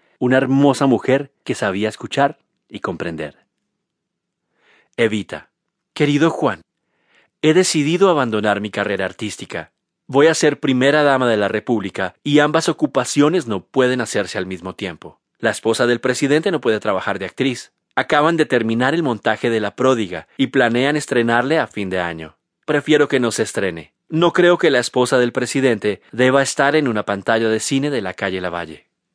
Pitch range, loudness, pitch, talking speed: 105-145 Hz, -18 LUFS, 125 Hz, 165 wpm